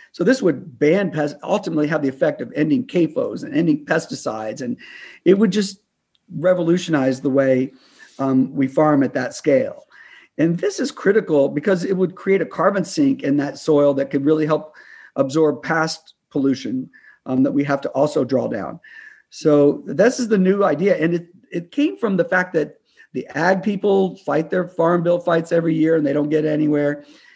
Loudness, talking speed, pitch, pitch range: -19 LUFS, 190 wpm, 165 Hz, 145-195 Hz